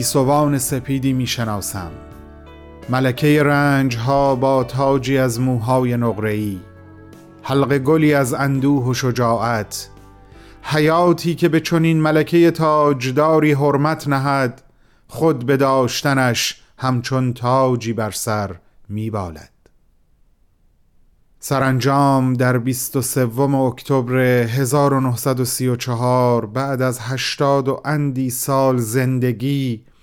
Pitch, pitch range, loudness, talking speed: 130 Hz, 115-140 Hz, -18 LUFS, 95 wpm